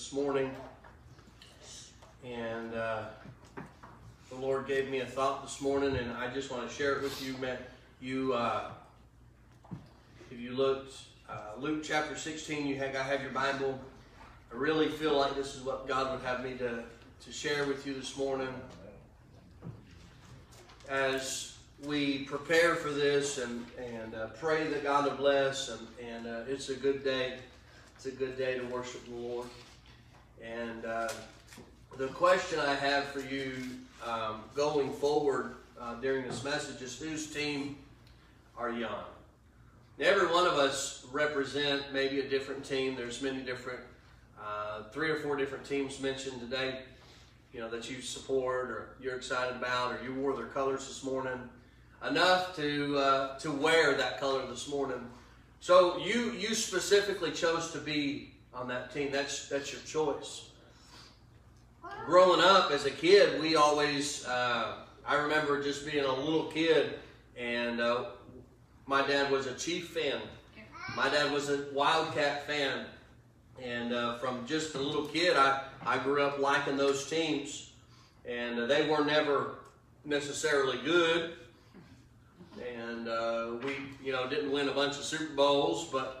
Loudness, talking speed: -32 LUFS, 155 wpm